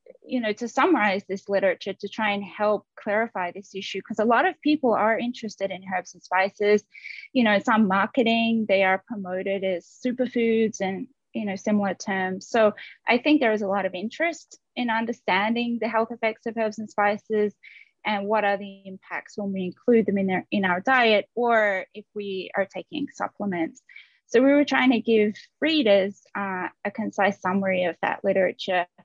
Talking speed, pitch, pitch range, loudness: 185 wpm, 210 Hz, 195-230 Hz, -24 LUFS